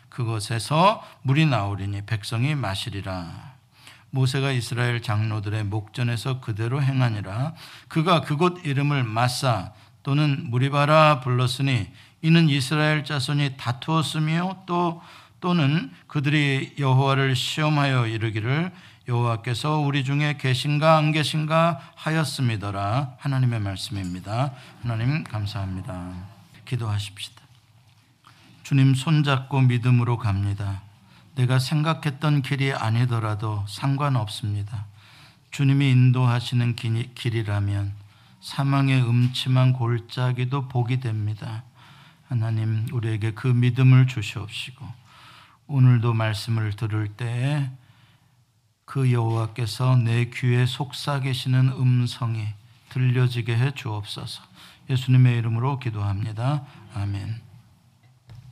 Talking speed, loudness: 265 characters per minute, -23 LUFS